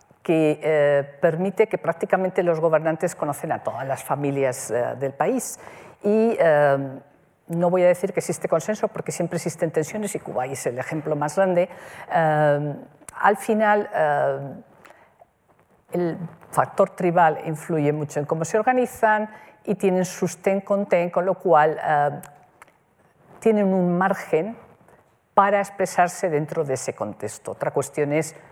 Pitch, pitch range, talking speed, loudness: 170 Hz, 150-195 Hz, 145 wpm, -22 LUFS